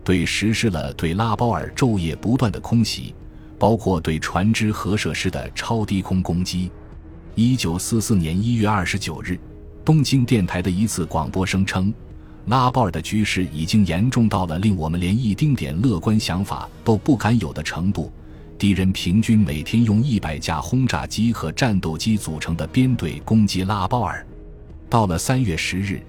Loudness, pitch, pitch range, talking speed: -21 LUFS, 95 Hz, 80-110 Hz, 265 characters per minute